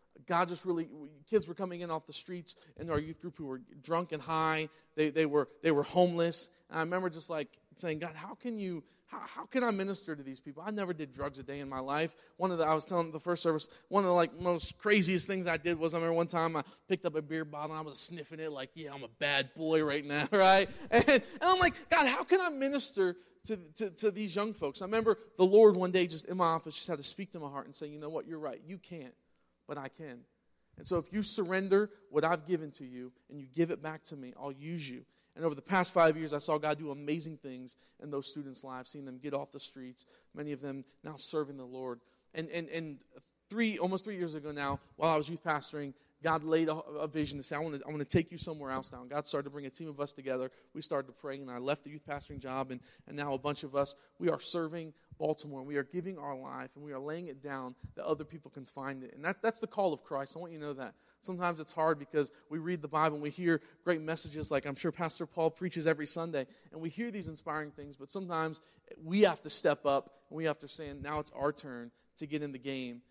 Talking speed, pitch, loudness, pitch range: 270 wpm, 155 Hz, -34 LUFS, 145-175 Hz